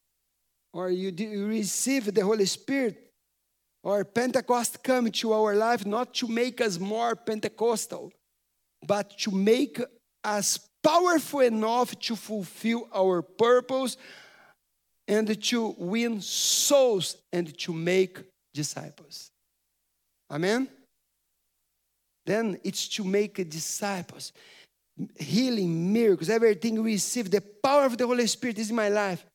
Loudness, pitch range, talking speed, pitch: -27 LUFS, 195-240 Hz, 115 wpm, 215 Hz